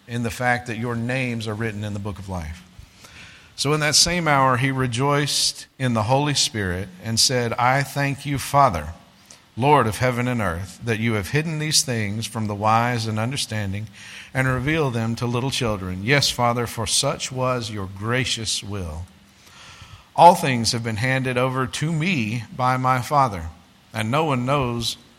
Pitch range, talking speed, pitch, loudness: 105-135 Hz, 180 wpm, 120 Hz, -21 LUFS